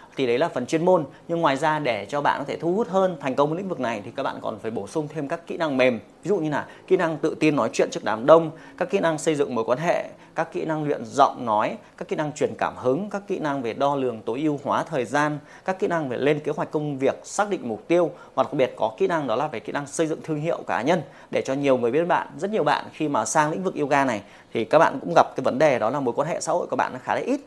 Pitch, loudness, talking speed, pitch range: 155 Hz, -24 LUFS, 315 wpm, 140-170 Hz